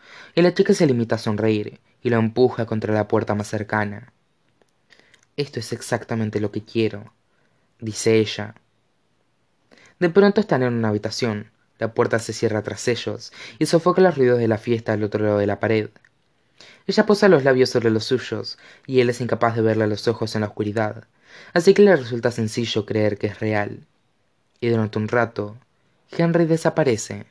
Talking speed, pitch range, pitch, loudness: 180 wpm, 110-130 Hz, 115 Hz, -21 LUFS